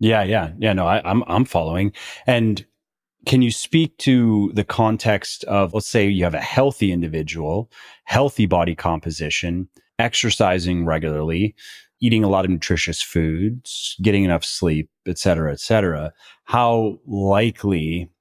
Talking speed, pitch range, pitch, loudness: 140 wpm, 85-110 Hz, 100 Hz, -20 LUFS